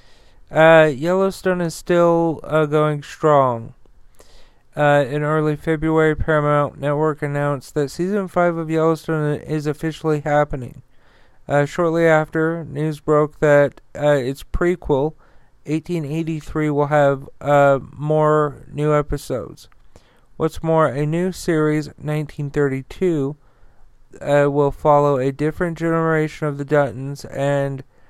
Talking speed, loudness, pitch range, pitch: 115 wpm, -19 LUFS, 145-160 Hz, 150 Hz